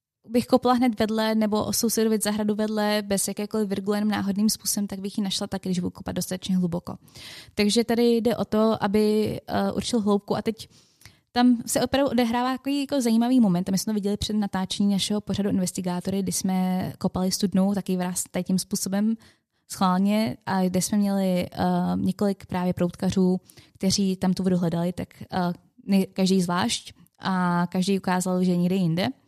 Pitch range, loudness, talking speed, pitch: 185-215 Hz, -24 LUFS, 170 wpm, 200 Hz